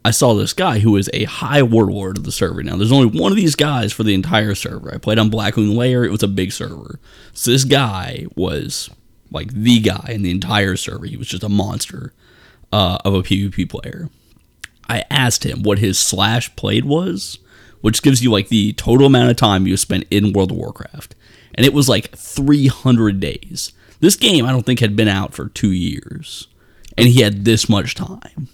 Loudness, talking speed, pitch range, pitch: -16 LUFS, 210 wpm, 100-125 Hz, 110 Hz